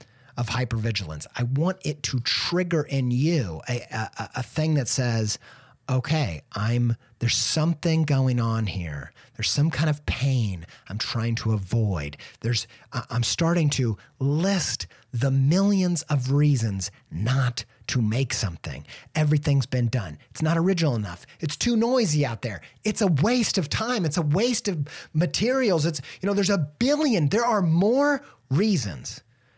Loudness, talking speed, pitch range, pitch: -25 LUFS, 155 wpm, 115-165 Hz, 135 Hz